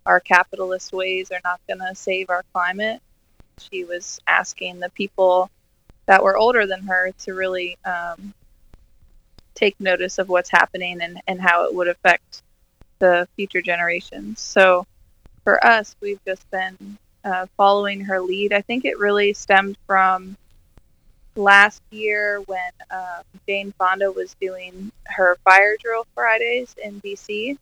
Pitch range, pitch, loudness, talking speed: 180-200 Hz, 190 Hz, -19 LUFS, 145 wpm